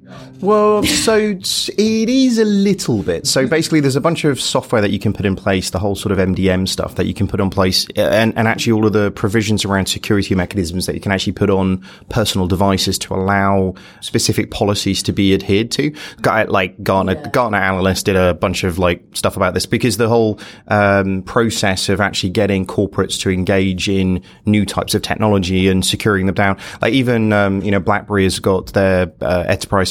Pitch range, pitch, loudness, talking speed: 95-110 Hz, 100 Hz, -16 LUFS, 205 wpm